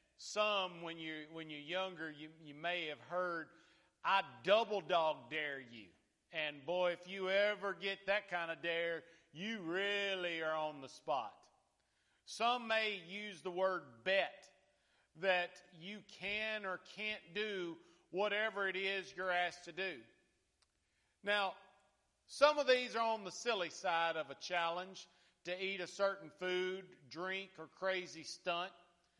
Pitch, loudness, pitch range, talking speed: 180 Hz, -39 LUFS, 165-195 Hz, 150 wpm